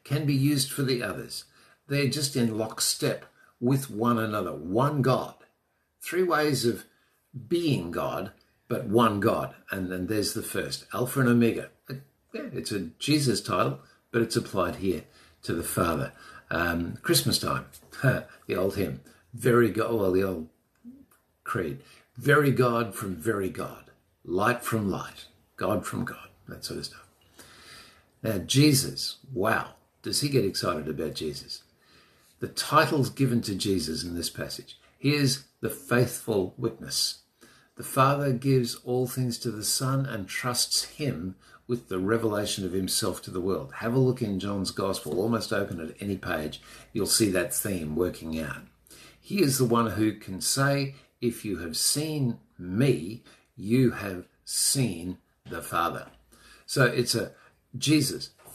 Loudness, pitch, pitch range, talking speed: -27 LUFS, 120 Hz, 95-130 Hz, 155 wpm